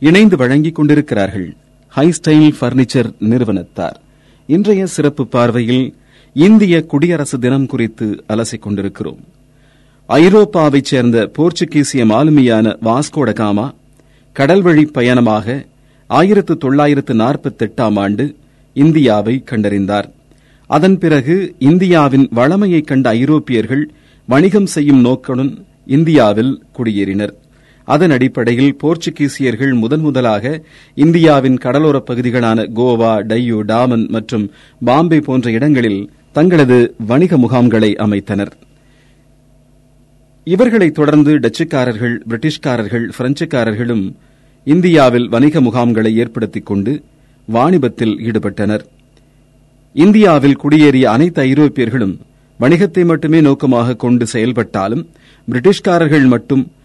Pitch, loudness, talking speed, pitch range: 130 Hz, -12 LUFS, 85 wpm, 115-150 Hz